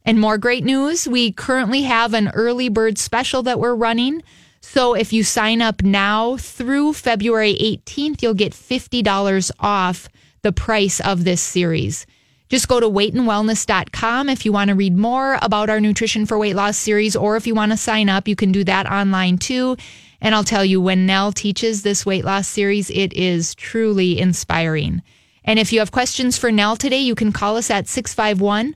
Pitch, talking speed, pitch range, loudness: 215 Hz, 190 wpm, 200-240 Hz, -17 LUFS